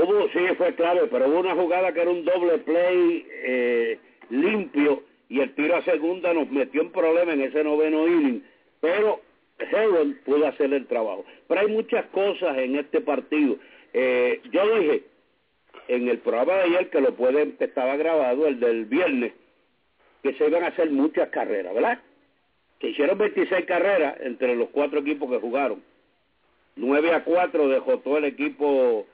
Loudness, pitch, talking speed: -23 LUFS, 175 Hz, 170 wpm